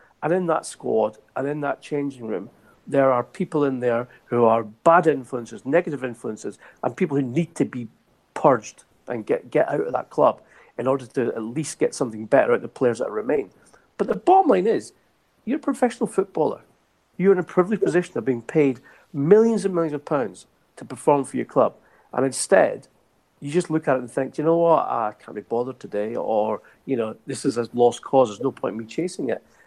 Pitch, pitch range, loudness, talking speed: 140 Hz, 125-170 Hz, -23 LUFS, 215 wpm